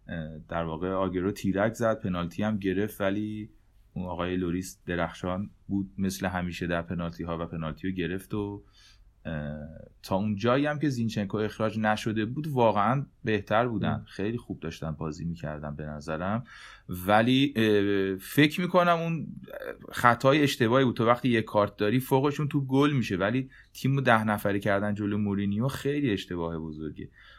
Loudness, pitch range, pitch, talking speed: -28 LUFS, 90-115 Hz, 105 Hz, 155 wpm